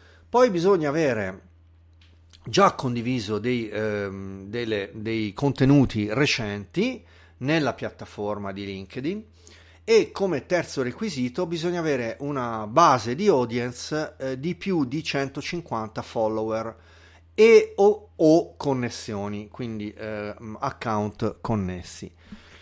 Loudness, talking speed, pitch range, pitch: -24 LUFS, 105 wpm, 105-150 Hz, 120 Hz